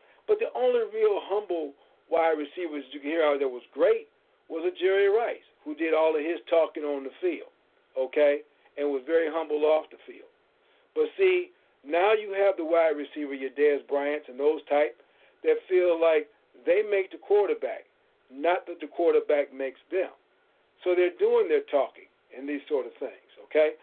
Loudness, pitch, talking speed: -27 LUFS, 180 Hz, 185 wpm